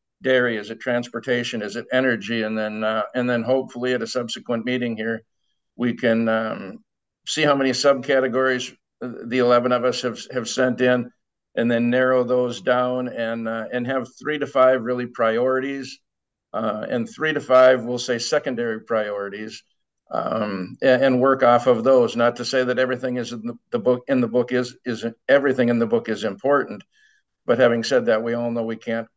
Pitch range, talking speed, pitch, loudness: 115-130 Hz, 190 wpm, 125 Hz, -21 LUFS